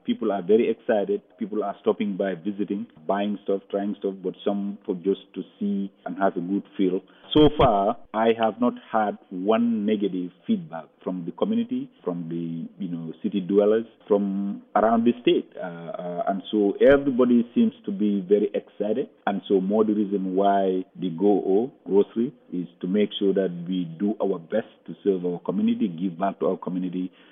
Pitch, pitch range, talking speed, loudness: 100 Hz, 95-110 Hz, 185 wpm, -25 LUFS